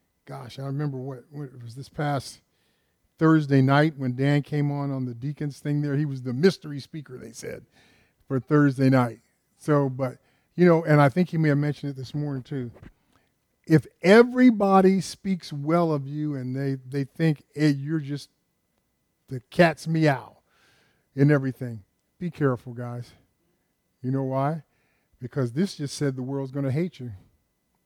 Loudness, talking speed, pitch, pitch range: -24 LUFS, 170 wpm, 140 Hz, 130-150 Hz